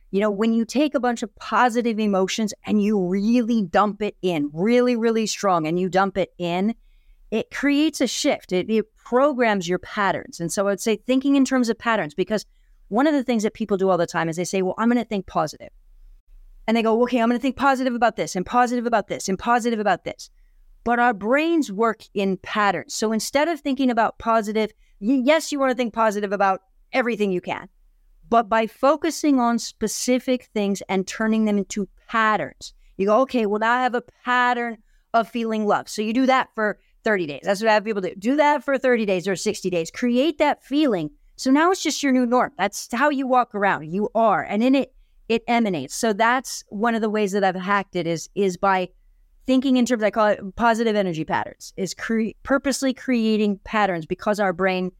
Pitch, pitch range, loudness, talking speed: 220 Hz, 200-250 Hz, -22 LUFS, 220 wpm